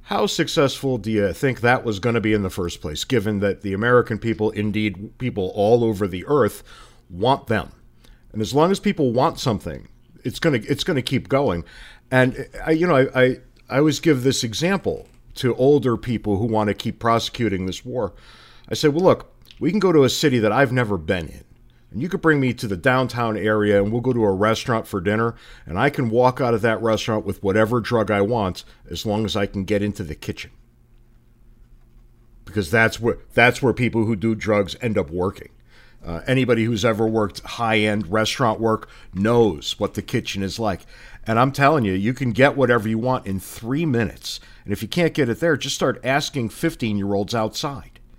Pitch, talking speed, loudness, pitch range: 115 Hz, 215 wpm, -21 LUFS, 105-130 Hz